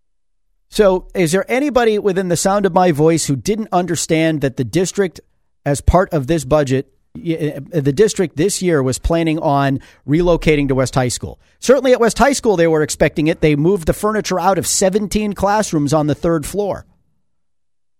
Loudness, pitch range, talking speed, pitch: -16 LUFS, 145-195 Hz, 180 wpm, 165 Hz